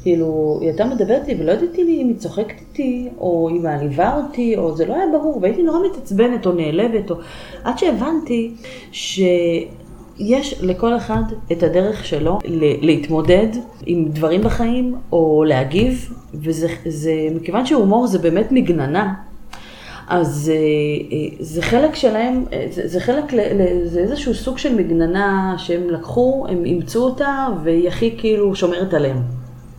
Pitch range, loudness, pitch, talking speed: 165-240 Hz, -18 LUFS, 185 Hz, 145 wpm